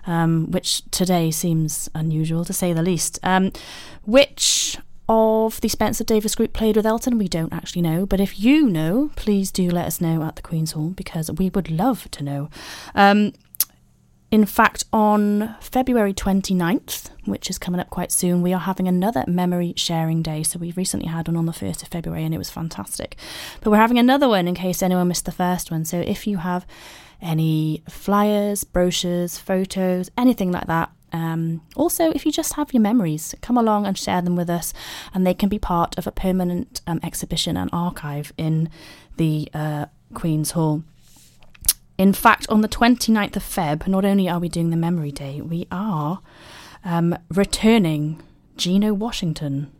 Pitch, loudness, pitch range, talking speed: 180 Hz, -21 LUFS, 165-205 Hz, 180 wpm